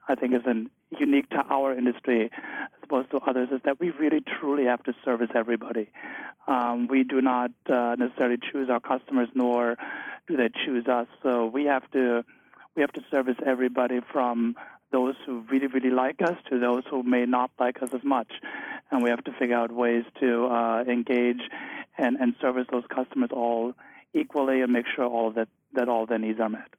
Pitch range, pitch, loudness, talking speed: 120-130 Hz, 125 Hz, -27 LUFS, 195 wpm